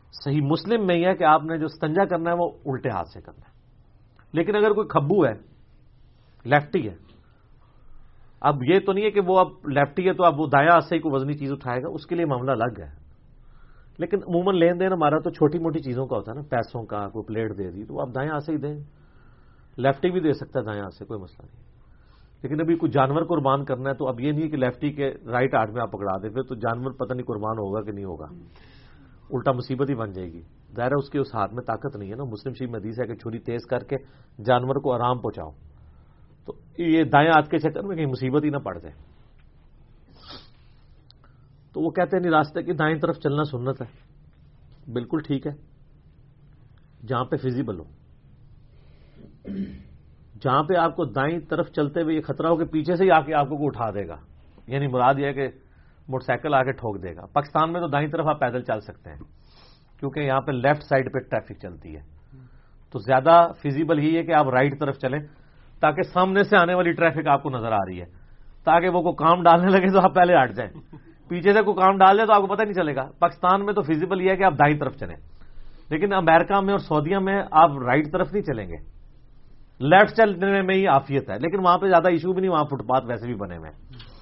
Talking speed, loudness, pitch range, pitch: 230 wpm, -22 LUFS, 120-165 Hz, 140 Hz